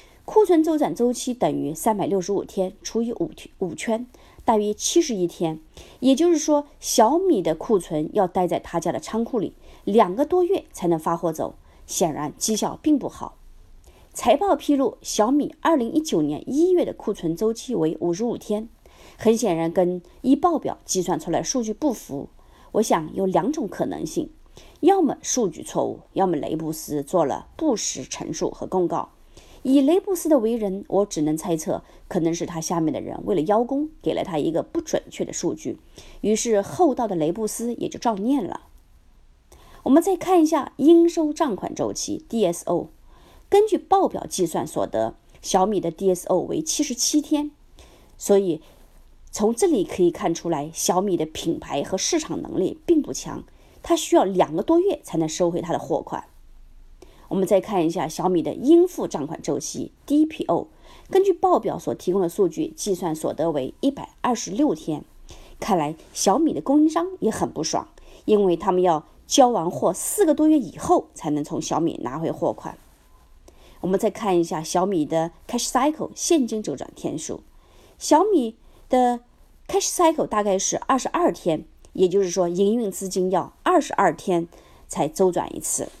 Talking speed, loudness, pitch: 265 characters per minute, -23 LUFS, 220 Hz